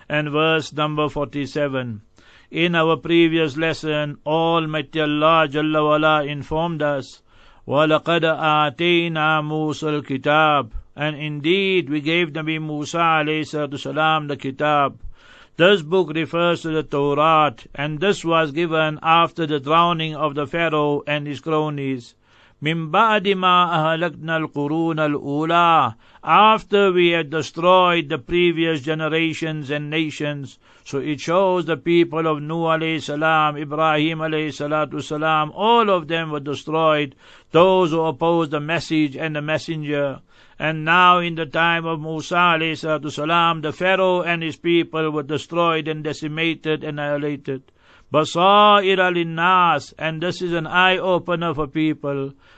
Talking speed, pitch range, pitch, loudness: 130 wpm, 150-170 Hz, 155 Hz, -19 LUFS